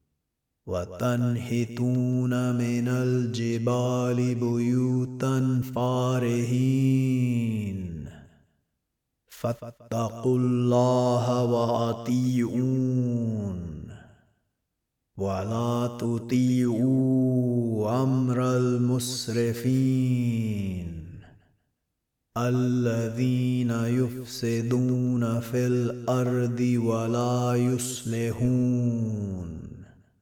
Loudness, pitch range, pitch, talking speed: -26 LUFS, 115-125 Hz, 120 Hz, 35 wpm